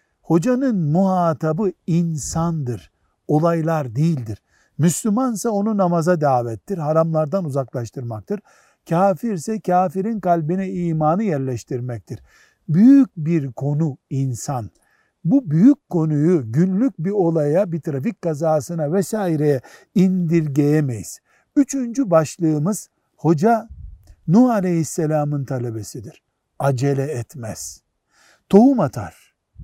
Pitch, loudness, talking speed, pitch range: 160 Hz, -19 LUFS, 85 wpm, 140-190 Hz